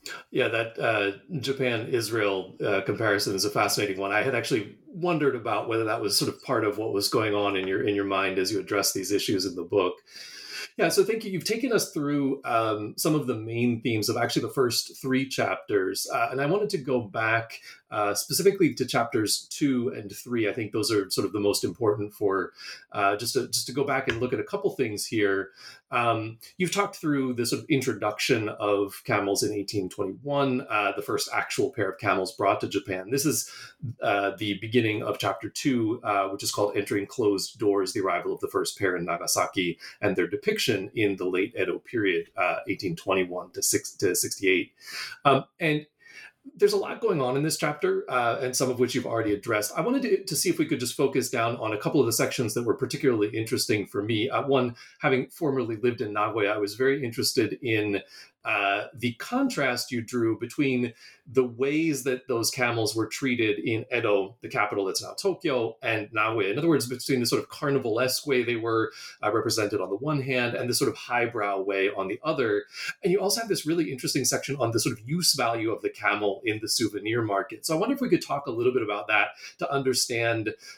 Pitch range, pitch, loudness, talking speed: 110-180 Hz, 130 Hz, -26 LUFS, 220 wpm